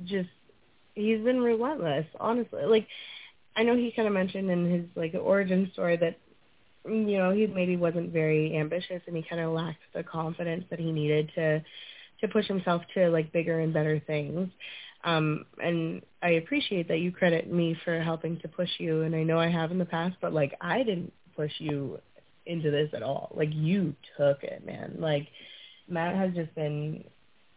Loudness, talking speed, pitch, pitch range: -29 LUFS, 185 wpm, 170 Hz, 160-185 Hz